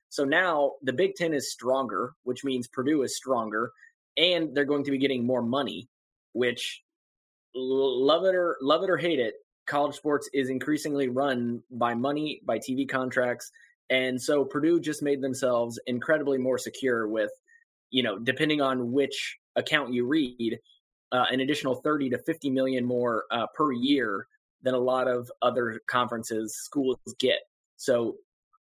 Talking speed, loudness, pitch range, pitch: 160 wpm, -27 LUFS, 125-150 Hz, 135 Hz